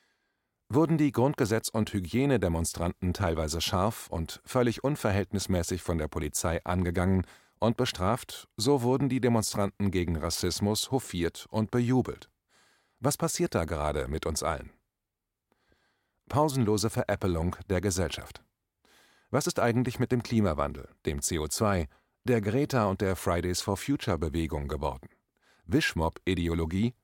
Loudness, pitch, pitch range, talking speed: -29 LUFS, 100 Hz, 85-120 Hz, 120 wpm